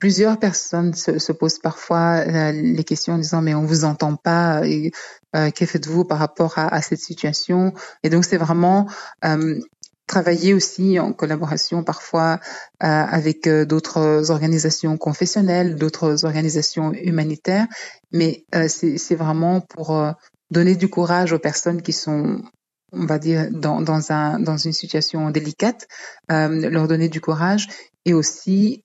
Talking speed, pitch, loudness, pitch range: 155 wpm, 165 Hz, -19 LUFS, 155-175 Hz